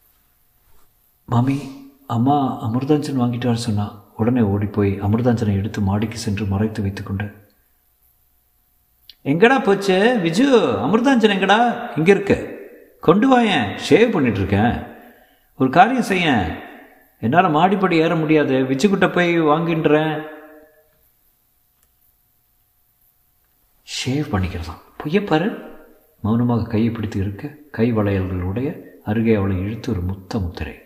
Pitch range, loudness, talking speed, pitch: 105-170 Hz, -18 LUFS, 95 wpm, 130 Hz